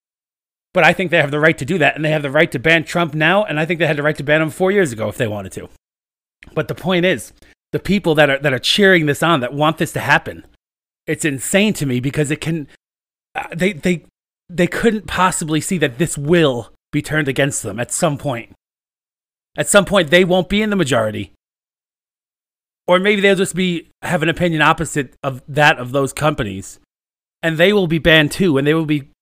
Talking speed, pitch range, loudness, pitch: 225 wpm, 140-175 Hz, -16 LUFS, 155 Hz